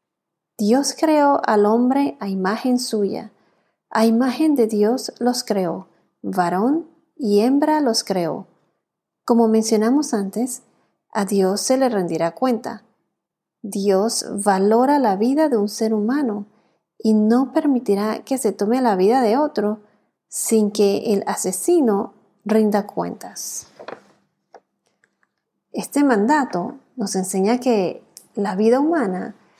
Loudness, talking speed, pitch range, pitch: -19 LUFS, 120 wpm, 205-255 Hz, 220 Hz